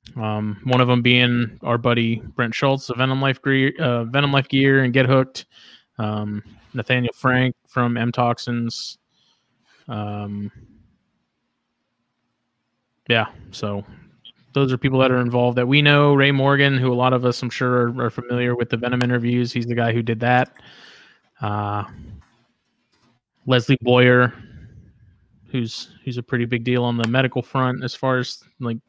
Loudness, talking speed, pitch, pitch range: -20 LUFS, 160 wpm, 125 Hz, 115-130 Hz